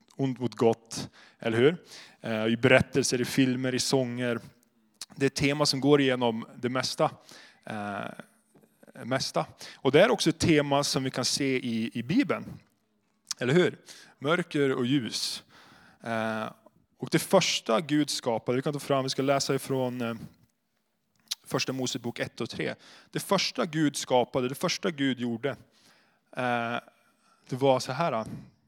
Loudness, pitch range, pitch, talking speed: -28 LUFS, 120-145 Hz, 130 Hz, 140 wpm